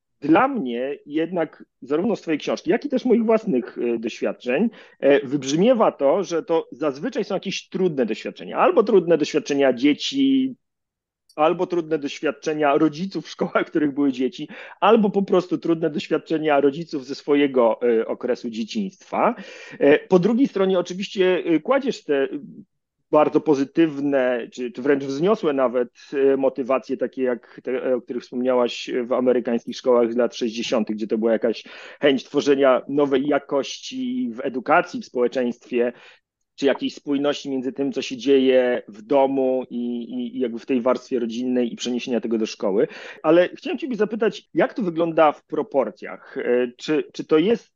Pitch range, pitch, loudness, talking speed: 125-185 Hz, 145 Hz, -22 LUFS, 150 wpm